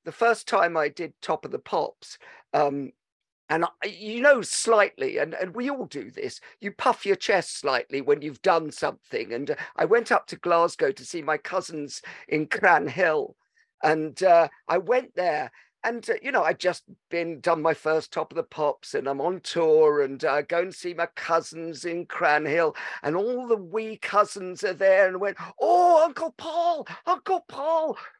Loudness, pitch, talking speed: -25 LUFS, 200 Hz, 185 wpm